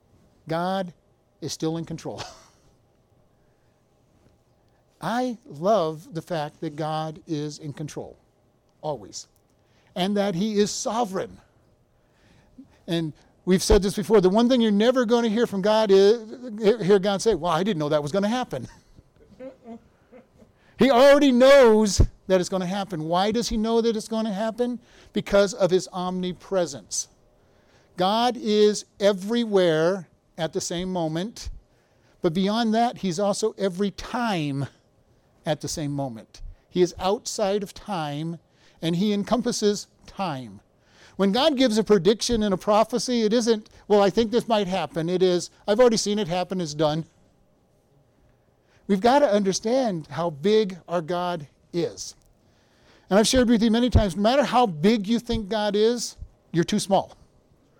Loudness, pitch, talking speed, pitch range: -23 LUFS, 200 Hz, 155 wpm, 170-225 Hz